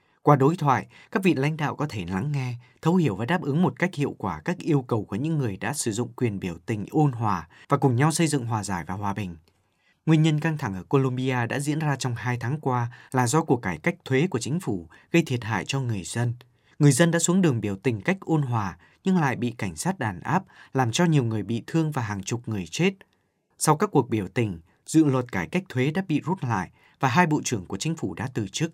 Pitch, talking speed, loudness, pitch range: 130 Hz, 260 wpm, -25 LUFS, 110-155 Hz